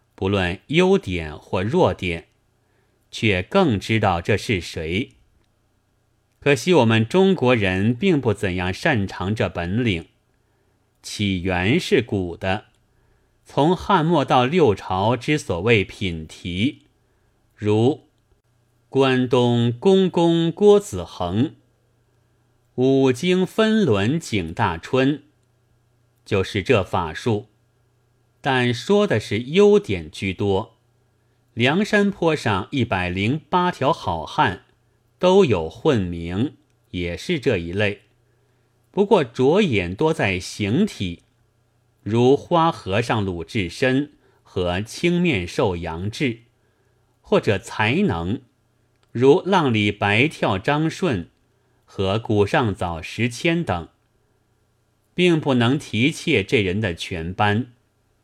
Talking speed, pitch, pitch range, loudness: 145 characters per minute, 115 Hz, 100-130 Hz, -20 LUFS